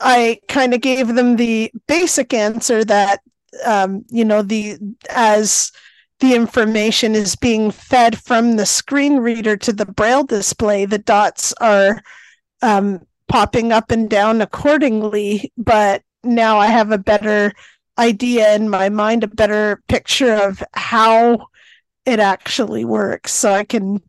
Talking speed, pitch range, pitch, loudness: 140 wpm, 210-240 Hz, 220 Hz, -15 LUFS